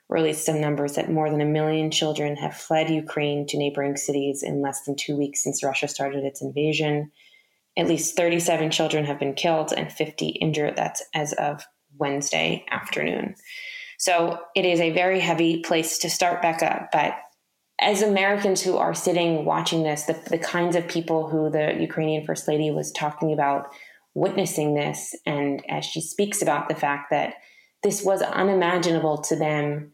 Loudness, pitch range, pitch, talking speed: -24 LUFS, 150-170 Hz, 155 Hz, 175 wpm